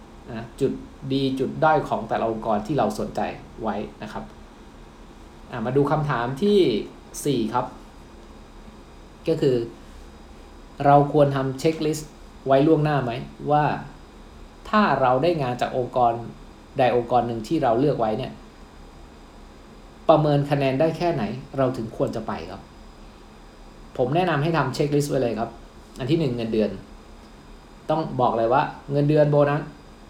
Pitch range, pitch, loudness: 105-150 Hz, 130 Hz, -23 LUFS